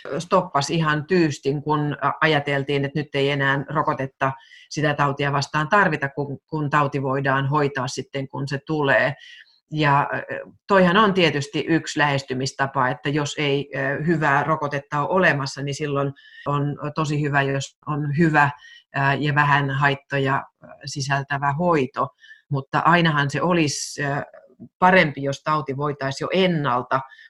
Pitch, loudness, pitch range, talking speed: 145 Hz, -21 LUFS, 140-155 Hz, 125 wpm